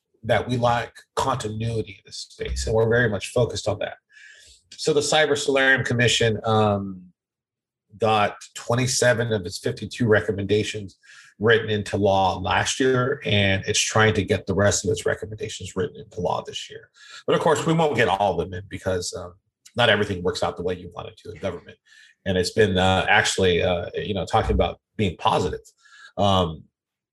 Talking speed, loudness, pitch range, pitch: 185 wpm, -22 LUFS, 100-125 Hz, 110 Hz